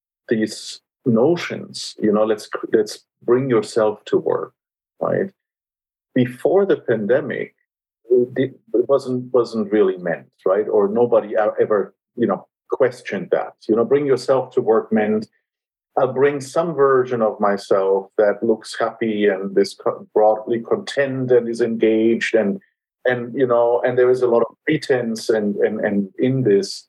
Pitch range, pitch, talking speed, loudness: 110-155 Hz, 125 Hz, 145 wpm, -19 LUFS